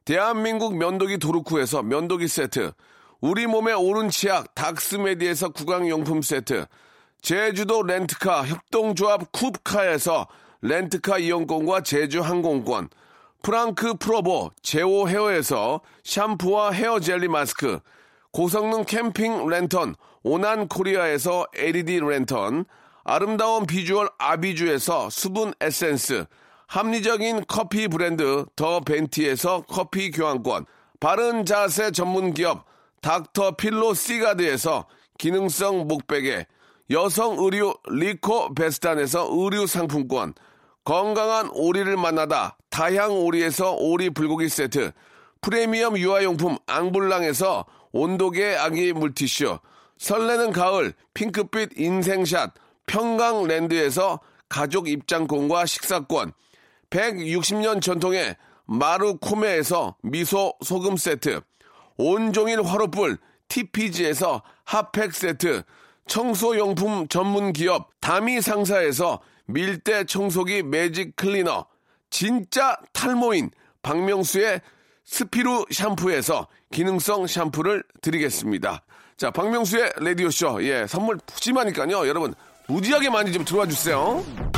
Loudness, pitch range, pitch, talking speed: -23 LUFS, 170-215 Hz, 190 Hz, 260 characters per minute